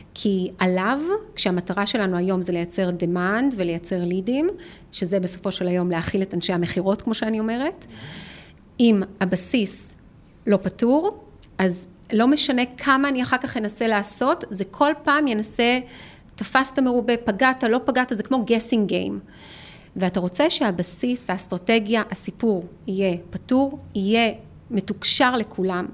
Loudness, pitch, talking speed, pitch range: -21 LUFS, 210 Hz, 130 wpm, 185-250 Hz